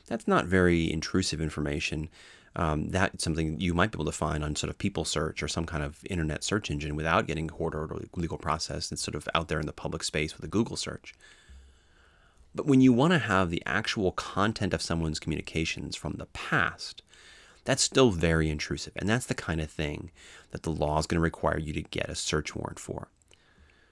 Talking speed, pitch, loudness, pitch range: 215 wpm, 80 Hz, -29 LUFS, 75-90 Hz